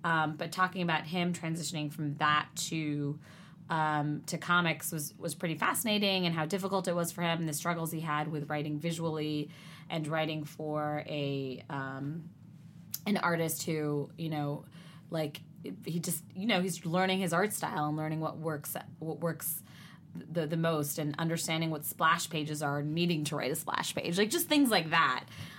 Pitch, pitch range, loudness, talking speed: 160 Hz, 150-170 Hz, -33 LUFS, 185 wpm